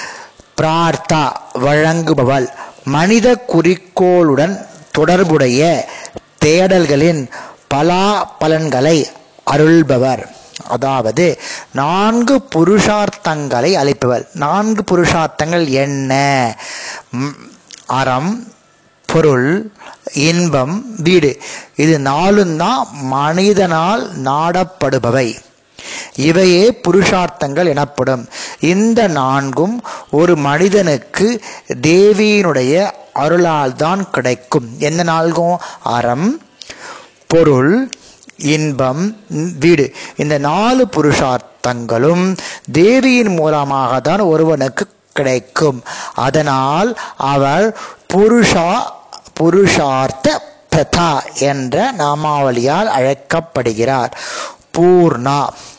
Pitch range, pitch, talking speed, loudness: 140-185 Hz, 160 Hz, 60 wpm, -13 LUFS